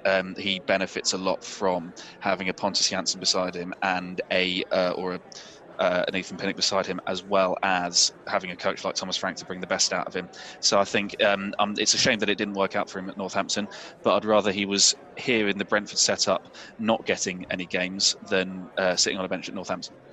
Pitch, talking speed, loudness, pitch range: 95 Hz, 235 wpm, -25 LUFS, 95-100 Hz